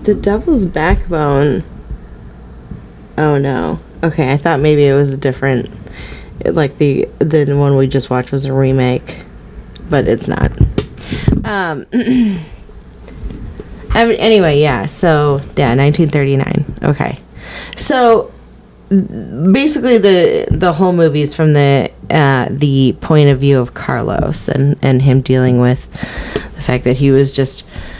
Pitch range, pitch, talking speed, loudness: 130-165 Hz, 140 Hz, 135 wpm, -13 LUFS